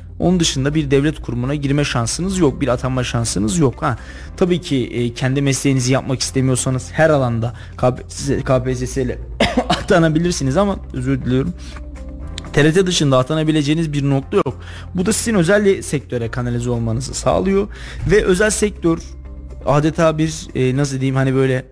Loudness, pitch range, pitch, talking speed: -17 LUFS, 120-155 Hz, 135 Hz, 140 wpm